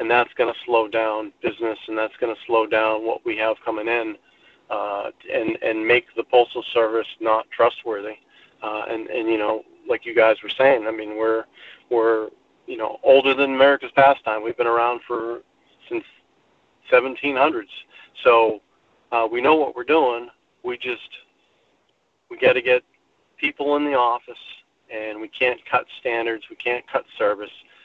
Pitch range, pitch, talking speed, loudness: 110-135 Hz, 120 Hz, 170 wpm, -21 LUFS